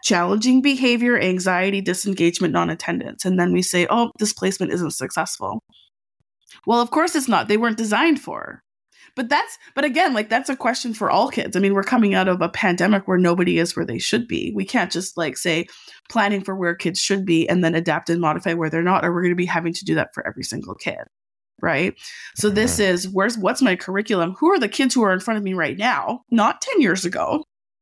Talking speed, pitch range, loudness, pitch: 225 wpm, 175-240 Hz, -20 LUFS, 195 Hz